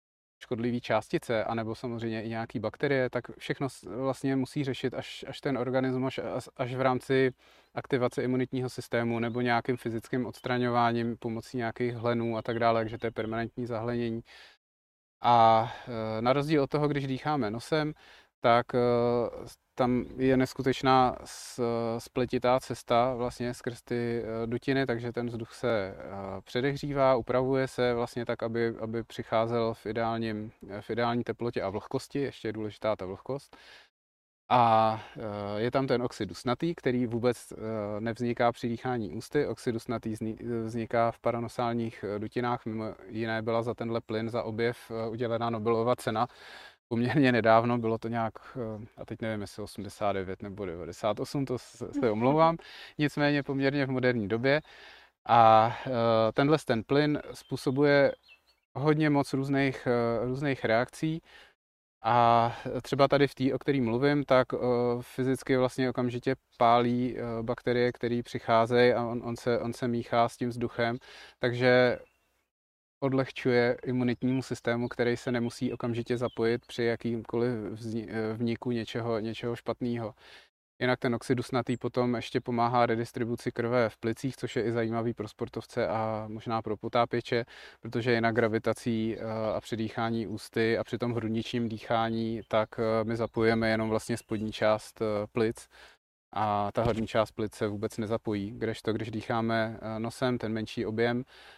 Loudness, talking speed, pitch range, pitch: -30 LUFS, 140 wpm, 115-125 Hz, 120 Hz